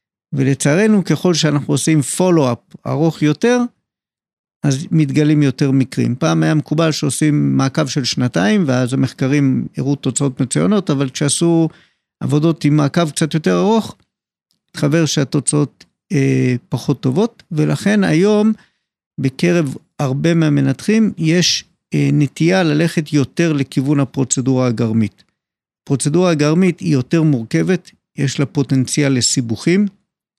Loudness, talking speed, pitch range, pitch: -16 LUFS, 115 wpm, 135-170 Hz, 150 Hz